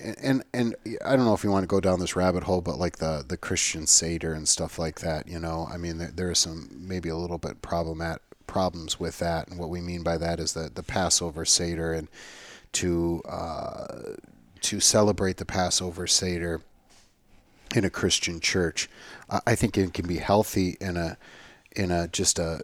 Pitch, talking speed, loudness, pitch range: 85 Hz, 200 wpm, -26 LUFS, 80-95 Hz